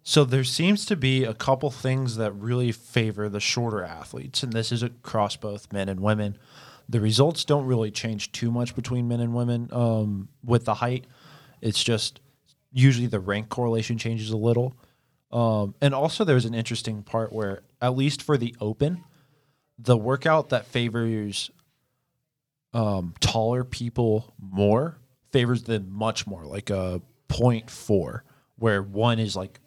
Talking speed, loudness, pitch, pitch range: 160 wpm, -25 LUFS, 120 Hz, 110-130 Hz